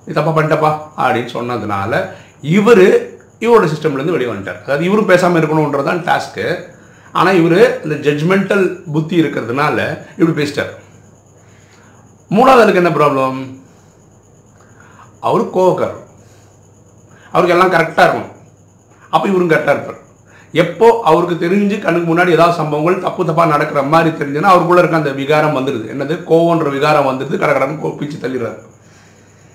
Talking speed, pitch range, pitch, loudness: 125 wpm, 120-175 Hz, 150 Hz, -13 LUFS